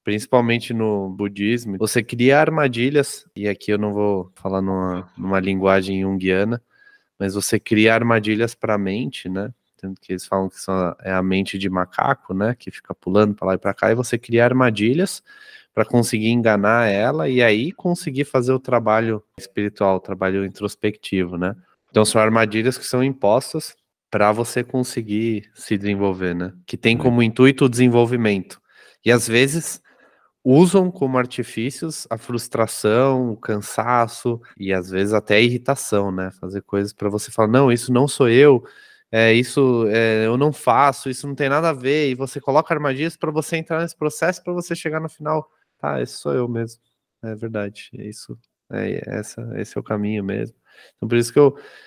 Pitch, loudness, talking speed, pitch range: 115 Hz, -19 LUFS, 180 wpm, 100-130 Hz